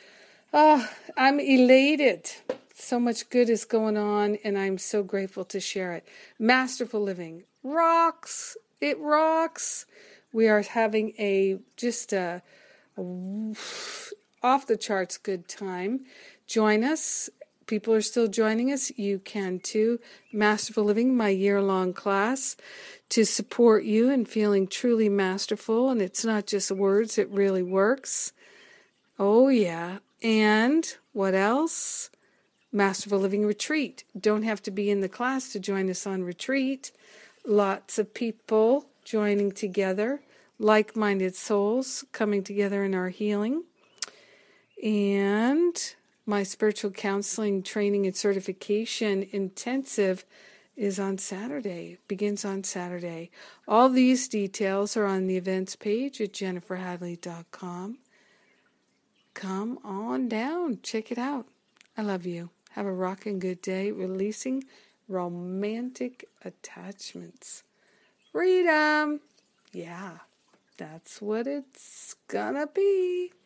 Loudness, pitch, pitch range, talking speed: -26 LUFS, 210 Hz, 195-245 Hz, 120 wpm